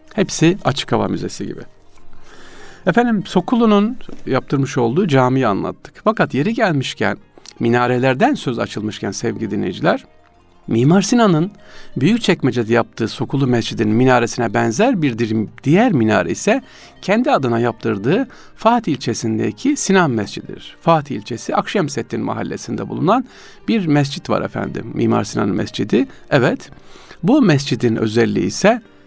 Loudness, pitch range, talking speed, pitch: -17 LUFS, 115-185 Hz, 115 wpm, 130 Hz